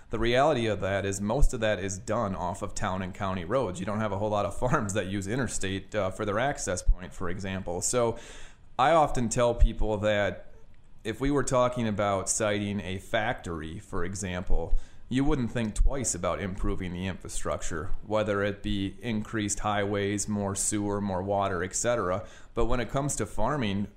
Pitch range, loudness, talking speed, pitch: 95-110 Hz, -29 LUFS, 185 wpm, 100 Hz